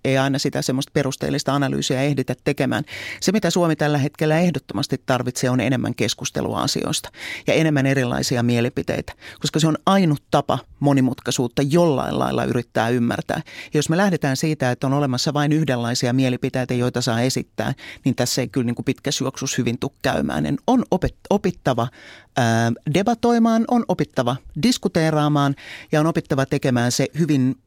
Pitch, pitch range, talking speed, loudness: 135 Hz, 125-155 Hz, 155 wpm, -21 LUFS